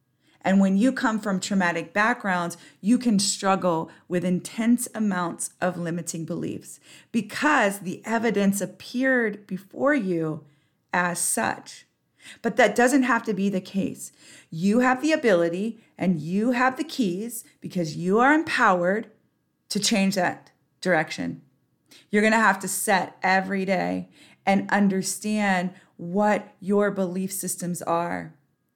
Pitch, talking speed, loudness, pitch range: 195 Hz, 135 wpm, -24 LUFS, 180-220 Hz